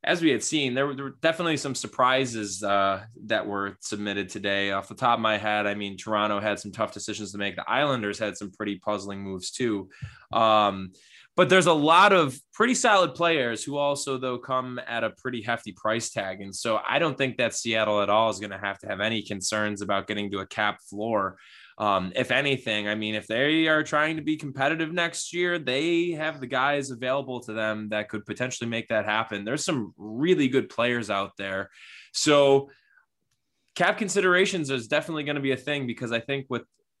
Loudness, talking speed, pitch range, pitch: -26 LUFS, 210 wpm, 105-145 Hz, 115 Hz